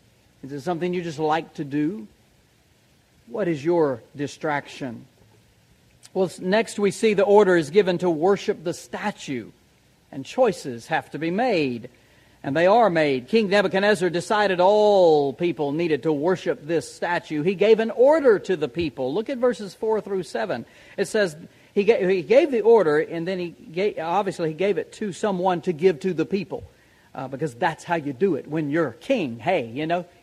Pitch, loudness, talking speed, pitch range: 180 Hz, -22 LUFS, 185 wpm, 155-205 Hz